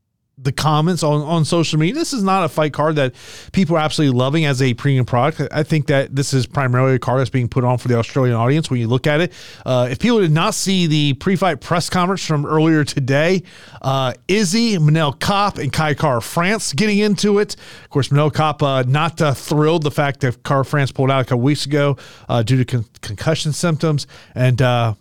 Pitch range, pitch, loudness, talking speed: 130-165 Hz, 150 Hz, -17 LUFS, 225 wpm